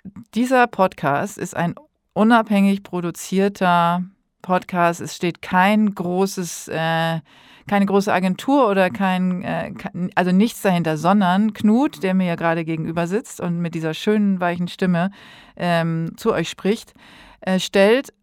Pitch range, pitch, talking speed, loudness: 175-210 Hz, 190 Hz, 120 wpm, -20 LUFS